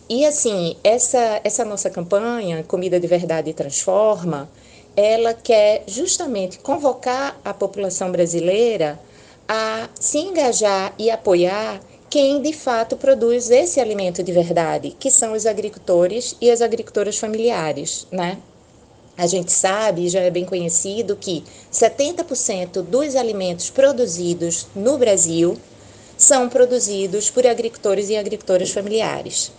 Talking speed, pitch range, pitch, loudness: 120 wpm, 180-240 Hz, 210 Hz, -19 LUFS